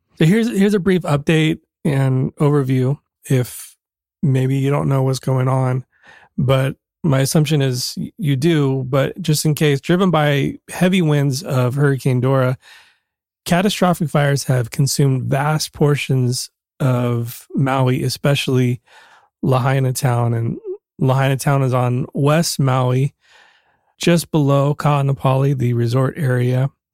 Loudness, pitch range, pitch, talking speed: -17 LUFS, 130-155 Hz, 135 Hz, 130 wpm